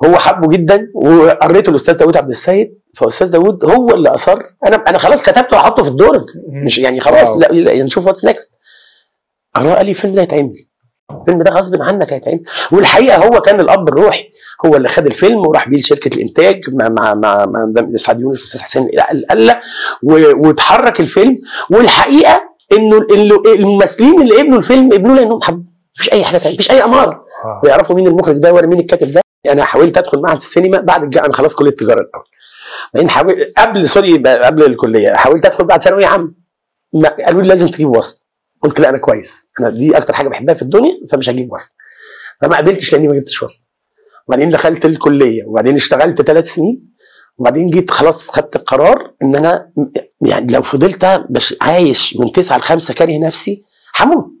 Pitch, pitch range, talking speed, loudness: 180 Hz, 155-210 Hz, 170 wpm, -9 LUFS